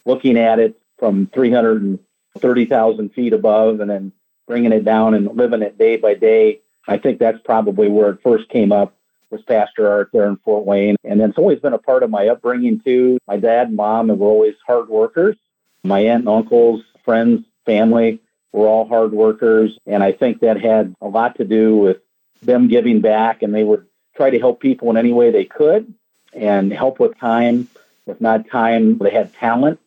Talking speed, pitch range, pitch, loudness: 195 wpm, 110-125 Hz, 115 Hz, -15 LUFS